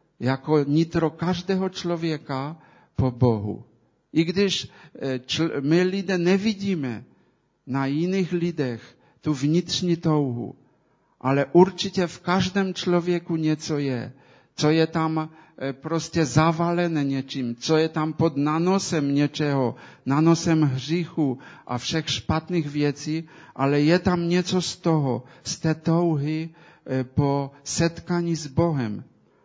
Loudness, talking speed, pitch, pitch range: -24 LUFS, 110 wpm, 155 Hz, 140-170 Hz